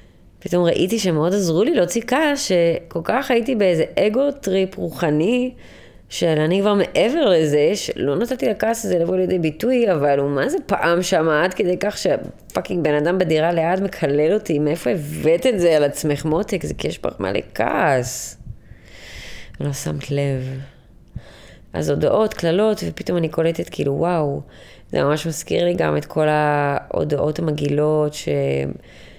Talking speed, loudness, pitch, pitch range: 155 wpm, -19 LUFS, 165 Hz, 150-190 Hz